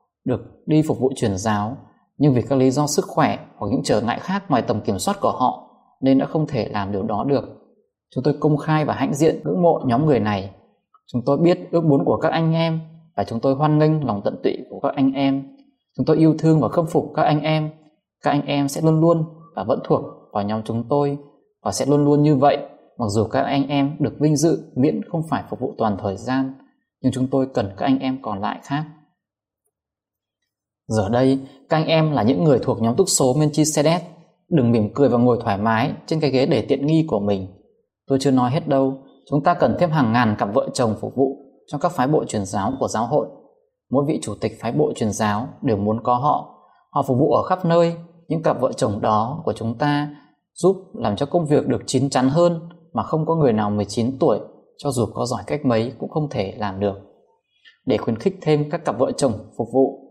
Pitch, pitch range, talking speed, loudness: 140 Hz, 120-160 Hz, 235 wpm, -20 LUFS